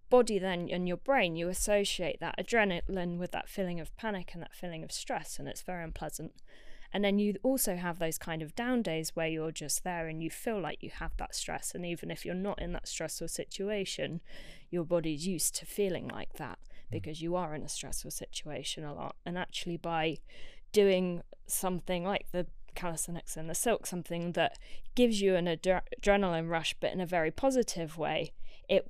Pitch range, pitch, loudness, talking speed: 165-195 Hz, 180 Hz, -34 LUFS, 200 wpm